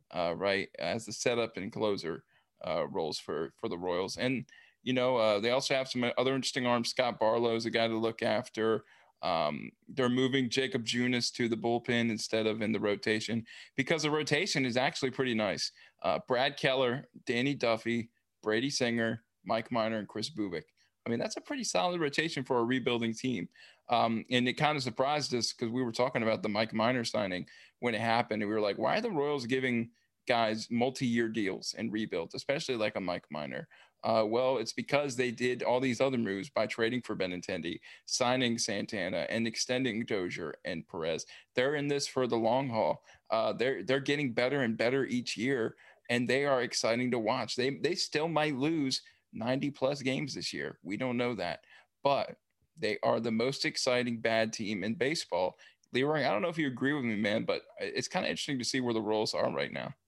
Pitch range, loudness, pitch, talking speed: 115-135 Hz, -32 LUFS, 125 Hz, 205 wpm